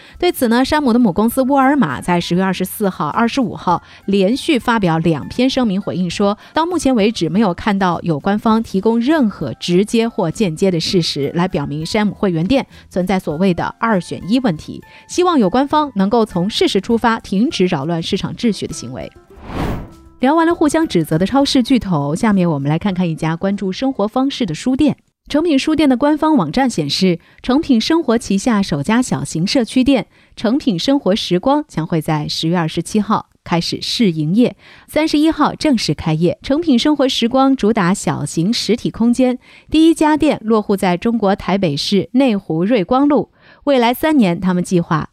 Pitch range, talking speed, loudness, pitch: 175-260 Hz, 295 characters per minute, -16 LUFS, 210 Hz